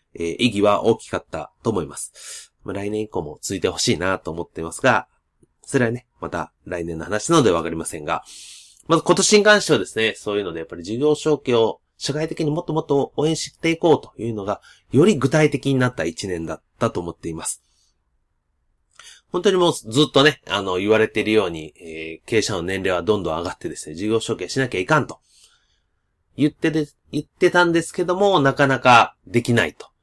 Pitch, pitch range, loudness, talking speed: 115 Hz, 90-150 Hz, -20 LUFS, 400 characters per minute